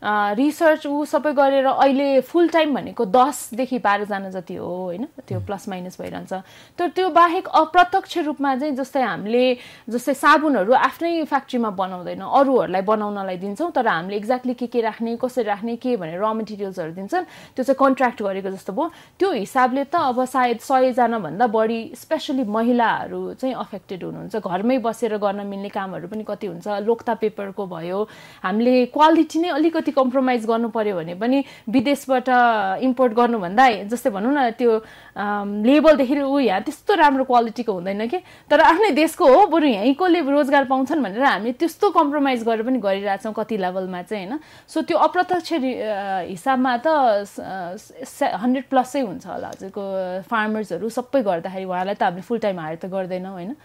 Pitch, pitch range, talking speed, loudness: 245 Hz, 205-280 Hz, 160 wpm, -20 LUFS